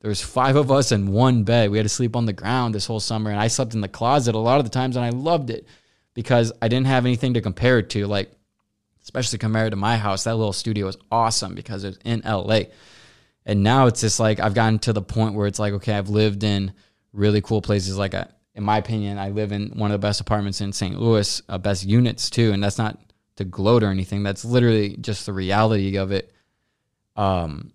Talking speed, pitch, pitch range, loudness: 240 wpm, 110 Hz, 100-115 Hz, -21 LUFS